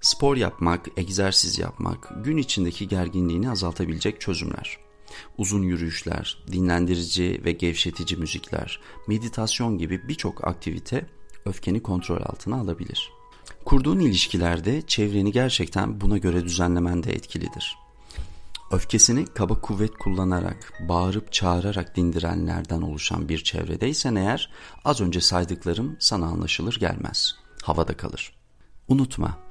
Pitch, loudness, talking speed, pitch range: 90 Hz, -24 LUFS, 105 wpm, 85-110 Hz